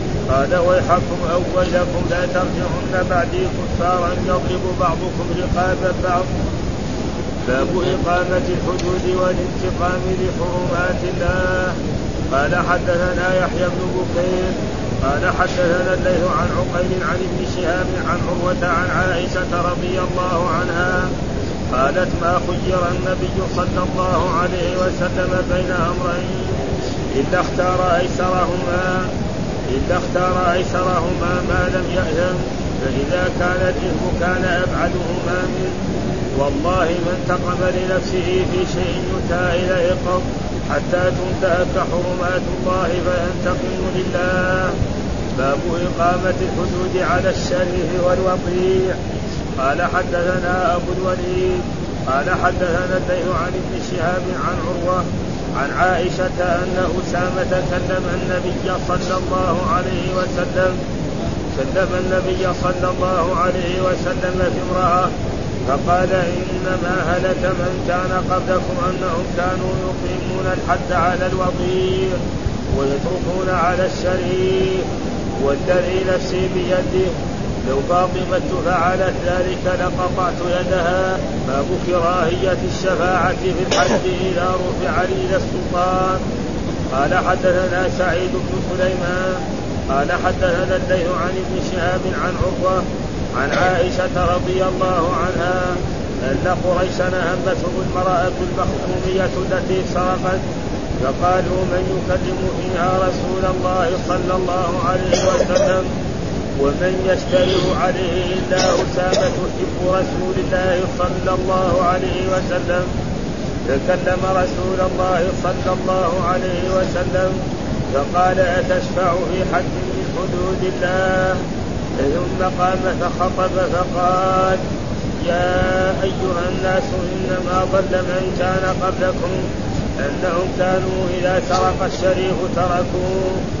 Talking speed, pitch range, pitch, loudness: 100 wpm, 175-185 Hz, 180 Hz, -19 LUFS